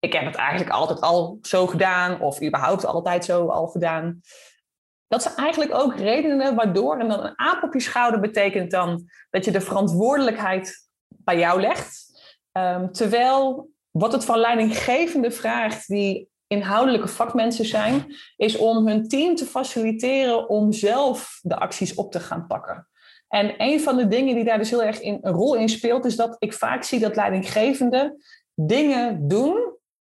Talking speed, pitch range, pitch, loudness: 170 wpm, 195-260 Hz, 225 Hz, -22 LUFS